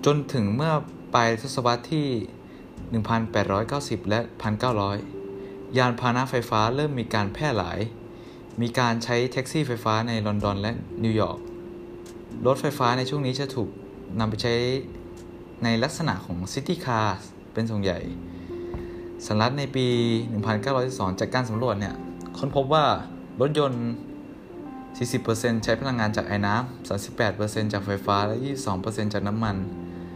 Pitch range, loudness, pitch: 100-130 Hz, -26 LUFS, 115 Hz